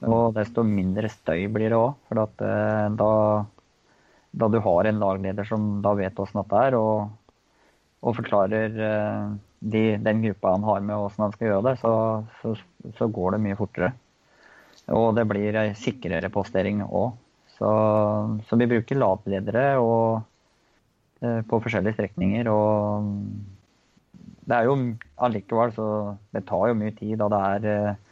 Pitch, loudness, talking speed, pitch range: 105 Hz, -24 LUFS, 145 wpm, 105-110 Hz